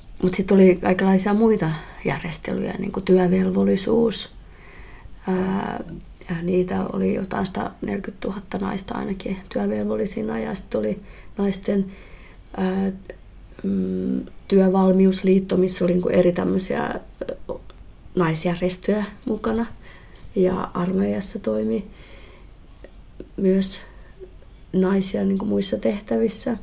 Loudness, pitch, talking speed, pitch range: -22 LUFS, 190 Hz, 80 wpm, 175-200 Hz